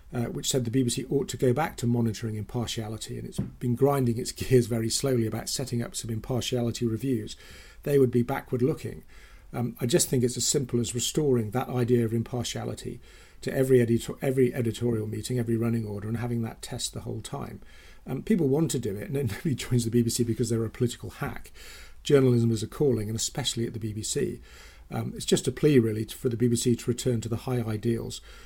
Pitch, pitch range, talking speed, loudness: 120 Hz, 115-130 Hz, 215 wpm, -27 LUFS